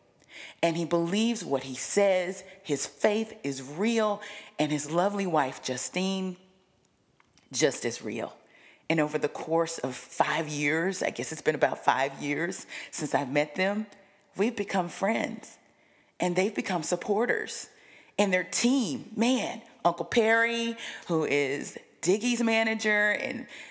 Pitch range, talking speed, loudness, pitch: 160-215 Hz, 135 wpm, -28 LUFS, 190 Hz